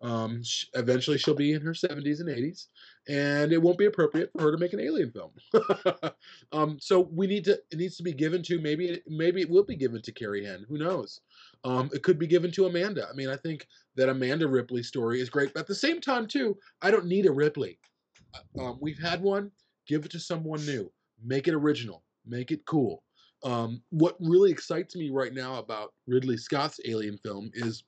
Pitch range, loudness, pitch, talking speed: 125-180 Hz, -28 LUFS, 150 Hz, 215 wpm